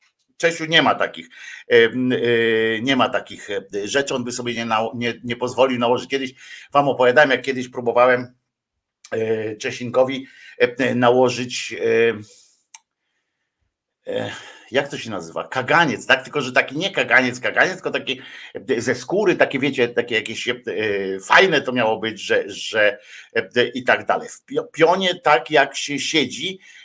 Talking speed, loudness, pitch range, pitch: 130 wpm, -19 LUFS, 120-145 Hz, 125 Hz